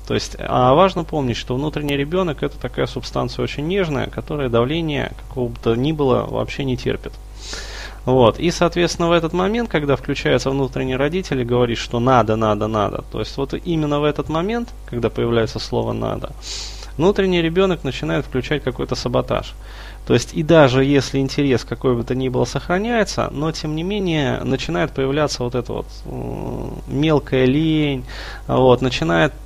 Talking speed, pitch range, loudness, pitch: 165 wpm, 125-155 Hz, -19 LUFS, 135 Hz